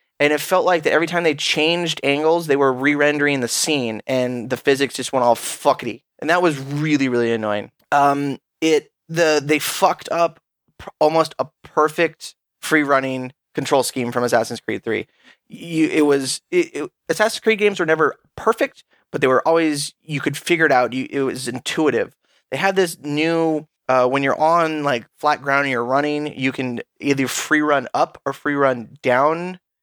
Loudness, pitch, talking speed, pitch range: -19 LUFS, 145 Hz, 190 wpm, 135-160 Hz